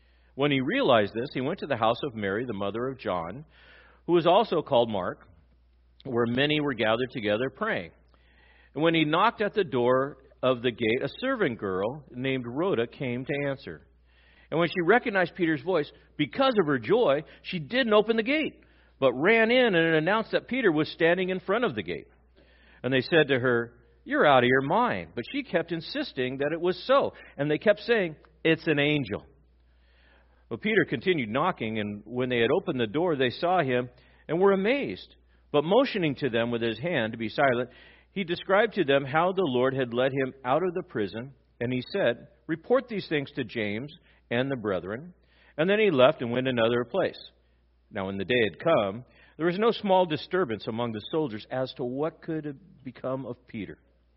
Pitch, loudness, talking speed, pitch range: 135 Hz, -26 LUFS, 200 wpm, 115-175 Hz